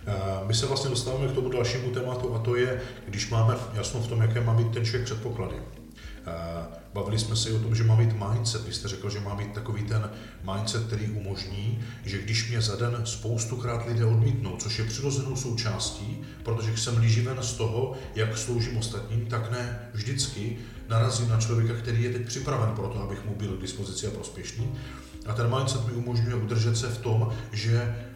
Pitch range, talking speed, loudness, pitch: 105-120 Hz, 195 wpm, -28 LUFS, 115 Hz